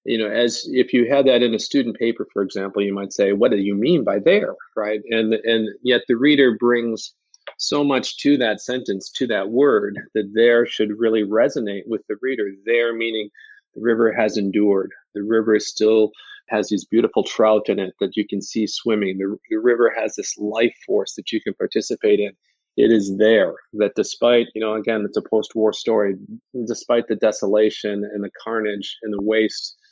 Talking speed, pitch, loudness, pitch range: 200 wpm, 110 Hz, -20 LUFS, 105-120 Hz